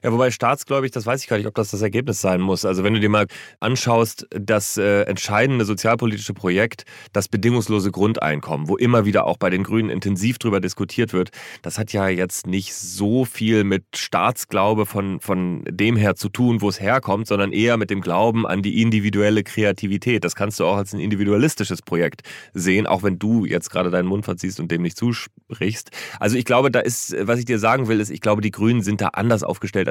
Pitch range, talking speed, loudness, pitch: 100-115 Hz, 215 wpm, -20 LUFS, 105 Hz